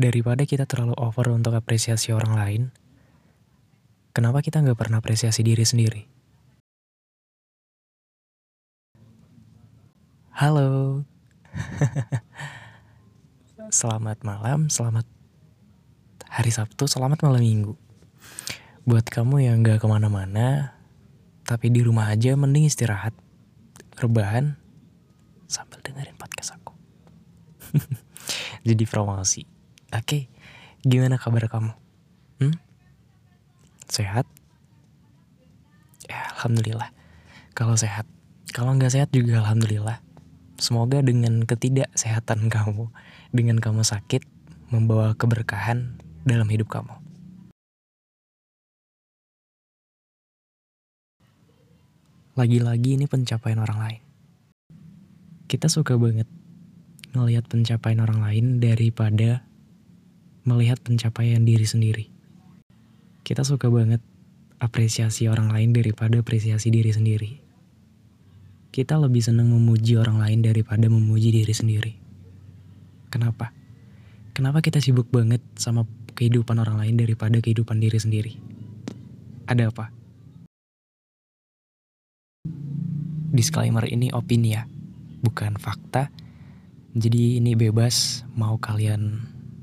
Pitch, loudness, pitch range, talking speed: 115 Hz, -23 LUFS, 110-135 Hz, 90 wpm